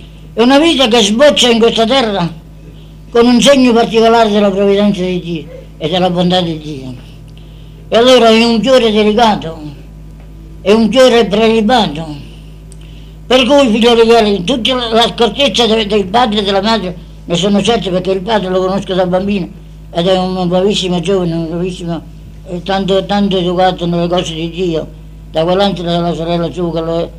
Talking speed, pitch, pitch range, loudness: 170 wpm, 185 Hz, 165-225 Hz, -11 LUFS